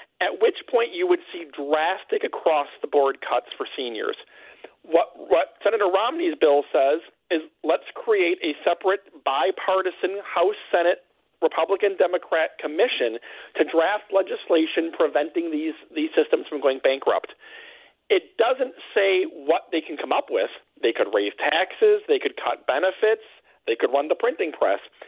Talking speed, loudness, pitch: 140 wpm, -23 LUFS, 375 Hz